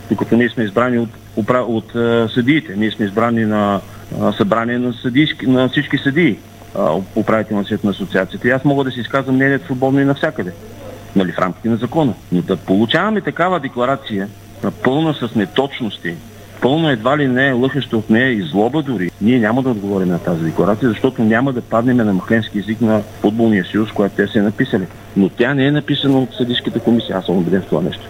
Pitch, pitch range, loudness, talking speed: 115 Hz, 105-130 Hz, -16 LUFS, 195 wpm